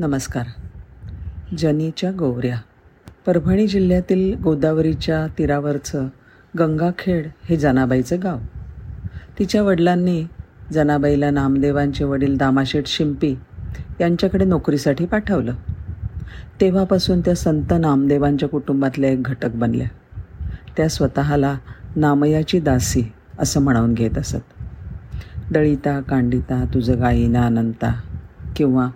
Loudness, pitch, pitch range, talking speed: -19 LUFS, 140 Hz, 120-160 Hz, 90 wpm